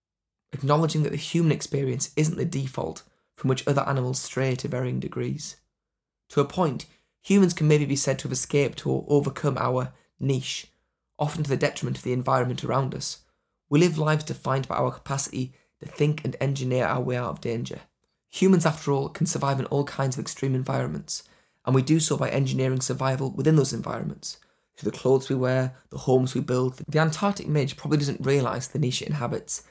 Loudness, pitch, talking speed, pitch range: -26 LUFS, 135 Hz, 195 wpm, 130-150 Hz